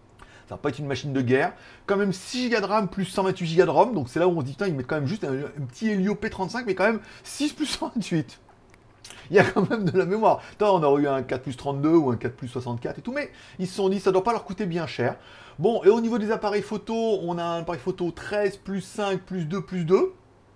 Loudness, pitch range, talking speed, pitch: -25 LUFS, 140-205 Hz, 290 wpm, 185 Hz